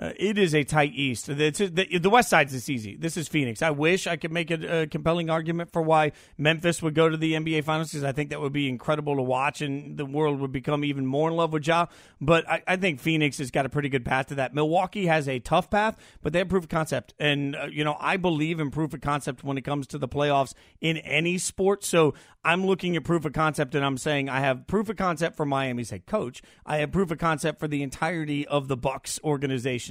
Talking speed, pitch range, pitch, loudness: 255 wpm, 140-165 Hz, 155 Hz, -26 LUFS